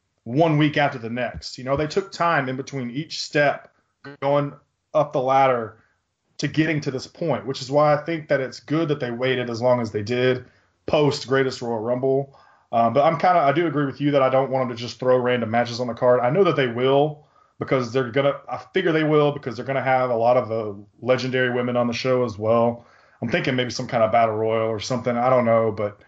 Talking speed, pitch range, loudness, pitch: 250 wpm, 120-145 Hz, -22 LUFS, 130 Hz